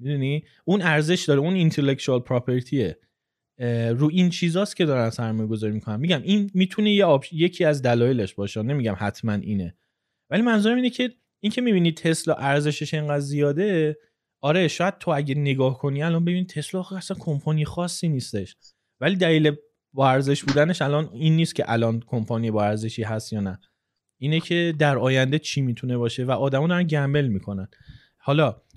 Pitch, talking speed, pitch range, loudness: 145 Hz, 165 wpm, 120-170 Hz, -23 LUFS